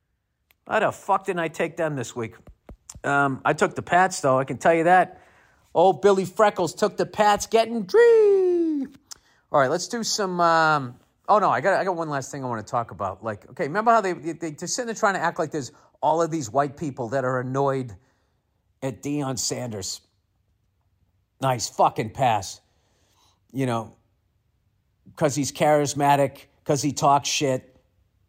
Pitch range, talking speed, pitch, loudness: 110-175 Hz, 180 wpm, 140 Hz, -23 LUFS